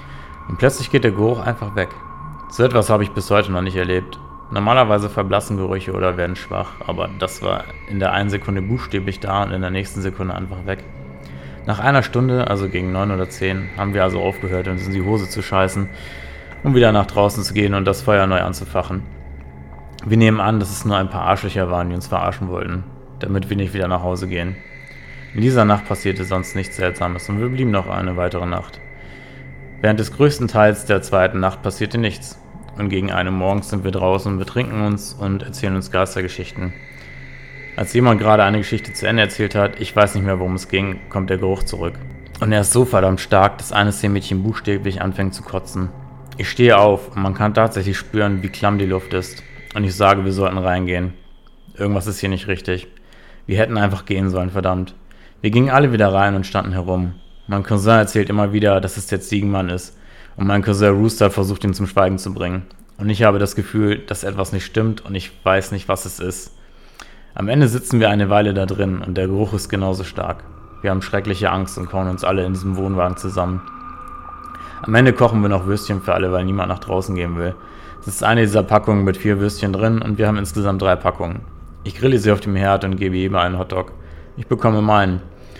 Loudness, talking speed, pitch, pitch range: -18 LUFS, 210 wpm, 95 Hz, 90-105 Hz